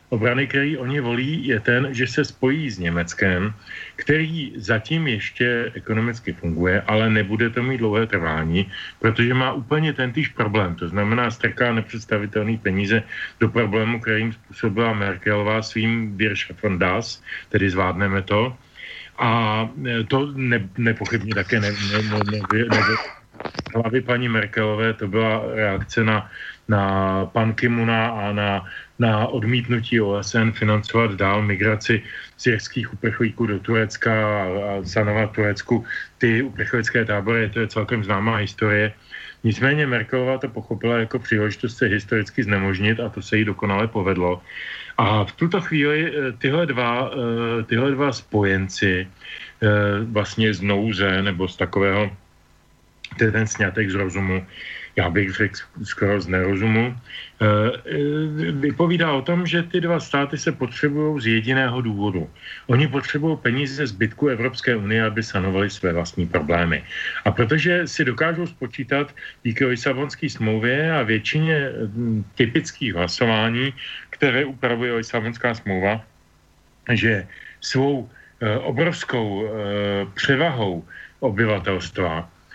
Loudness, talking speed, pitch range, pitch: -21 LUFS, 130 wpm, 100-125 Hz, 110 Hz